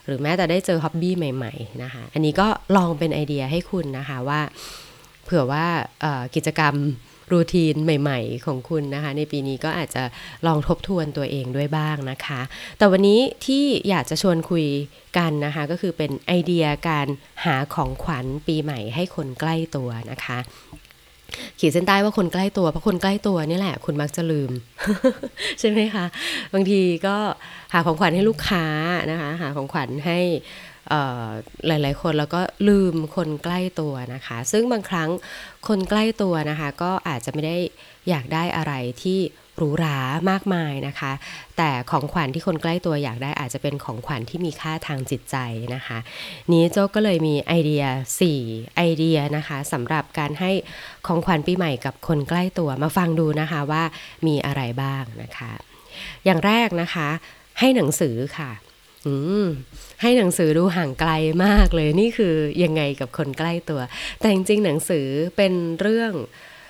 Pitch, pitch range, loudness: 160 Hz, 145-180 Hz, -22 LUFS